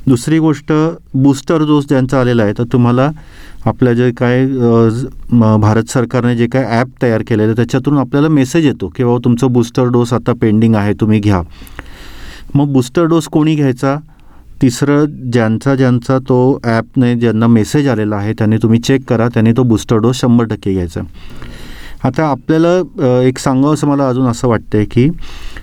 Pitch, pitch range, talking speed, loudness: 125 Hz, 115-135 Hz, 165 wpm, -12 LUFS